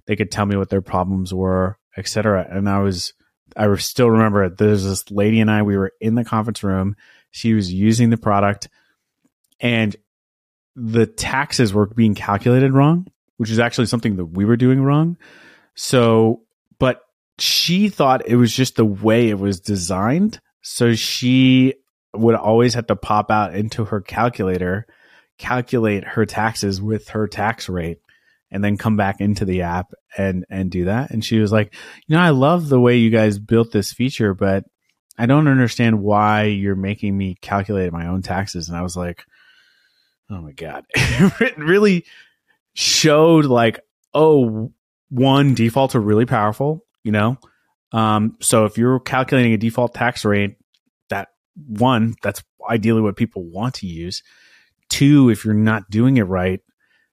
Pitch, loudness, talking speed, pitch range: 110 Hz, -18 LUFS, 165 wpm, 100-125 Hz